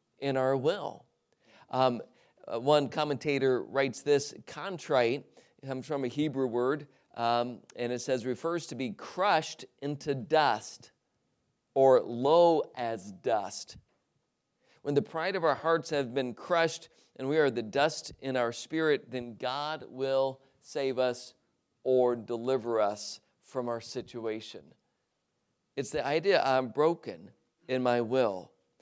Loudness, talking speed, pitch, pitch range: -30 LUFS, 135 wpm, 130 Hz, 120-145 Hz